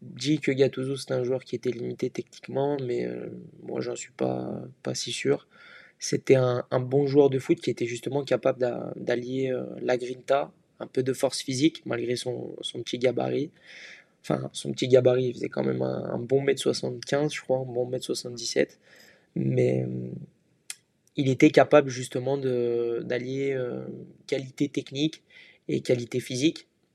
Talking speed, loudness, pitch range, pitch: 175 wpm, -27 LUFS, 120-140 Hz, 130 Hz